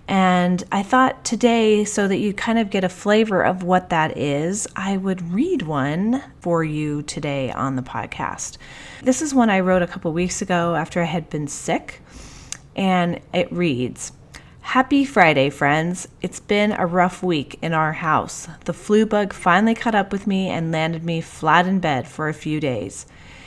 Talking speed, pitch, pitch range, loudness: 185 wpm, 180 Hz, 155-200 Hz, -20 LUFS